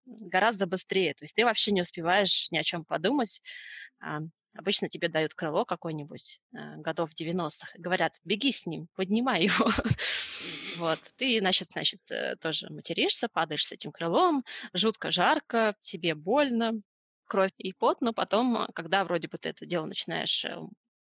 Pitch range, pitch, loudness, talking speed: 170-225 Hz, 190 Hz, -28 LUFS, 150 wpm